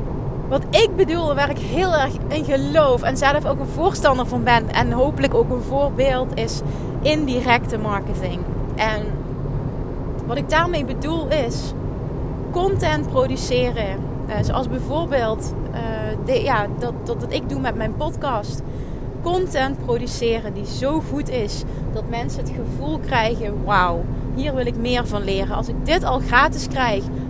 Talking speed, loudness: 150 wpm, -21 LUFS